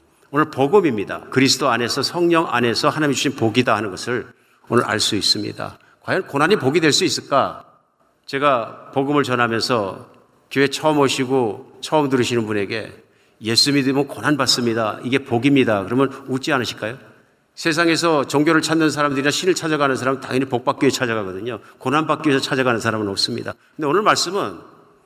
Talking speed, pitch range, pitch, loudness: 395 characters per minute, 120-145 Hz, 135 Hz, -19 LUFS